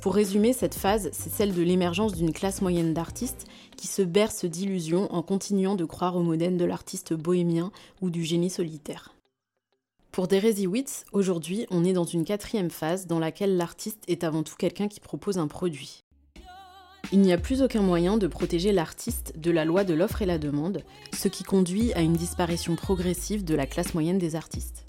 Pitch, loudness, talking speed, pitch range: 180 Hz, -27 LUFS, 190 wpm, 170-200 Hz